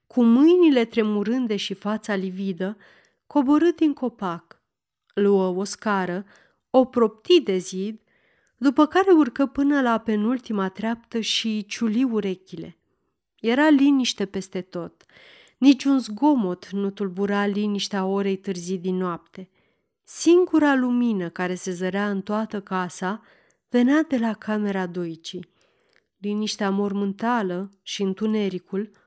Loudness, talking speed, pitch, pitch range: -23 LUFS, 115 wpm, 210 Hz, 195-245 Hz